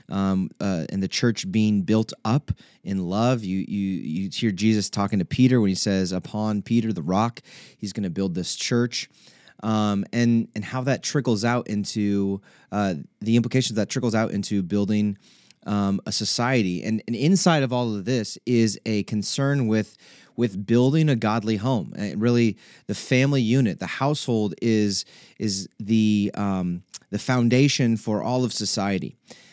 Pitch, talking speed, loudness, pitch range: 110 Hz, 170 wpm, -23 LUFS, 100-120 Hz